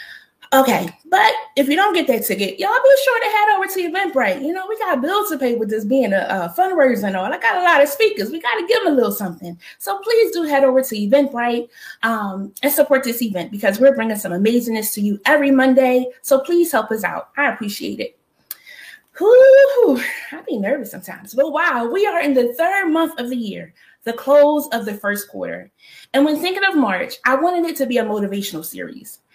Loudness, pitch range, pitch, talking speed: -17 LUFS, 225-345 Hz, 275 Hz, 225 wpm